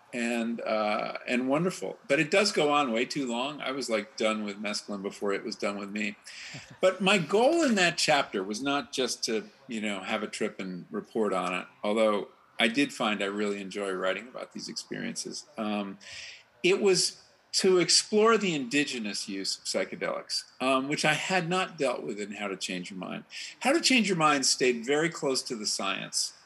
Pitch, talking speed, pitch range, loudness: 130 Hz, 200 wpm, 105-175 Hz, -28 LUFS